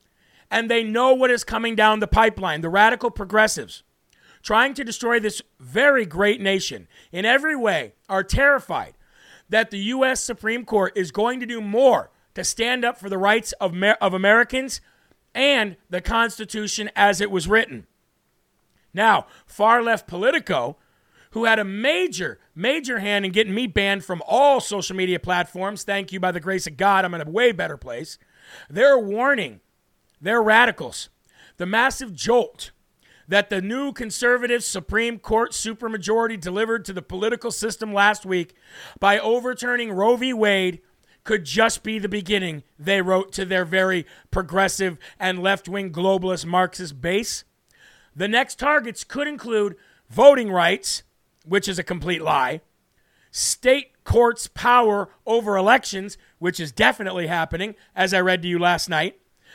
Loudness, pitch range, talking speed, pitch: -21 LUFS, 190-235 Hz, 155 wpm, 210 Hz